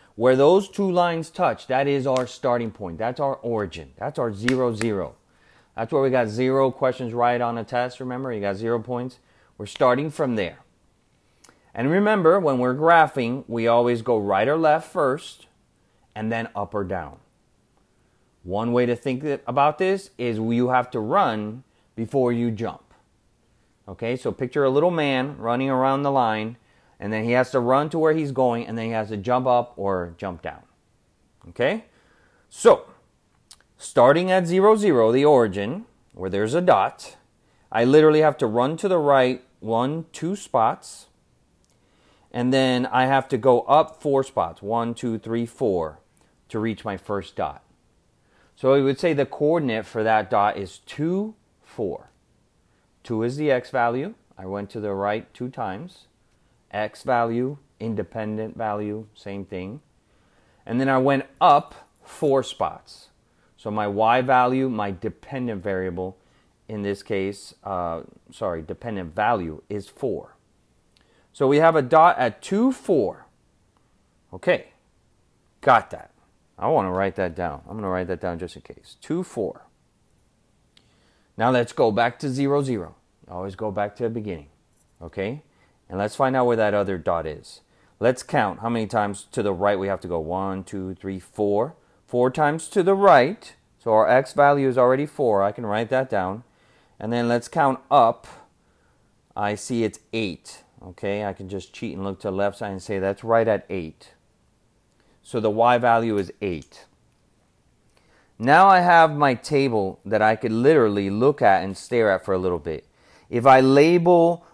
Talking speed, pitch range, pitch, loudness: 170 wpm, 100-135 Hz, 115 Hz, -22 LUFS